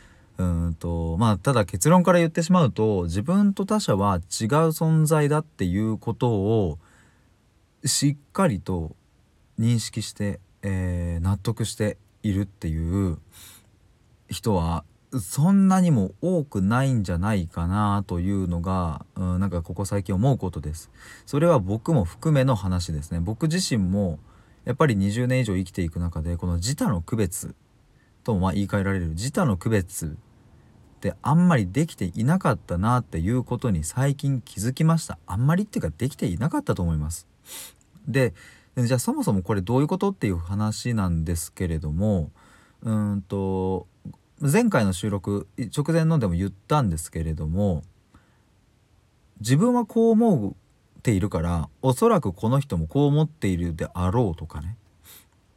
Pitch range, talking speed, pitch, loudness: 90-130 Hz, 315 characters per minute, 105 Hz, -24 LUFS